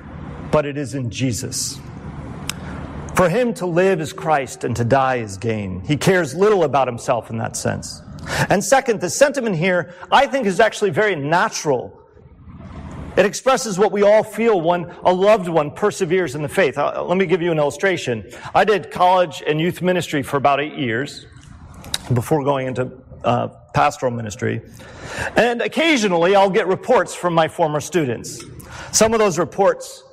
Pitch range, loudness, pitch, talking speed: 130-200 Hz, -18 LUFS, 170 Hz, 165 wpm